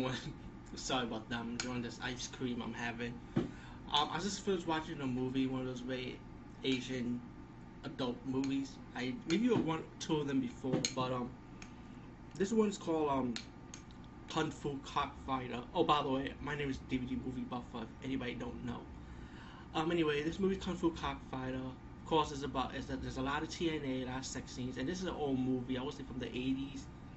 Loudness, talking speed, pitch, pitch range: -38 LUFS, 200 wpm, 130 Hz, 125-150 Hz